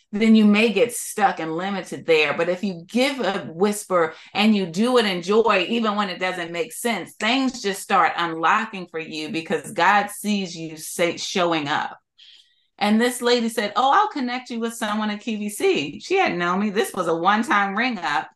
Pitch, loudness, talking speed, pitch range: 210 Hz, -21 LUFS, 205 wpm, 180-240 Hz